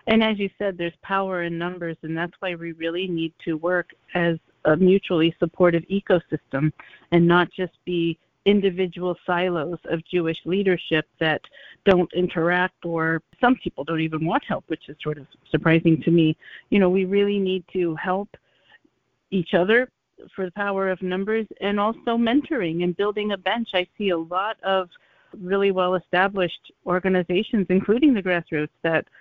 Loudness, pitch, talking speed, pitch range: -23 LUFS, 180 Hz, 165 wpm, 165-195 Hz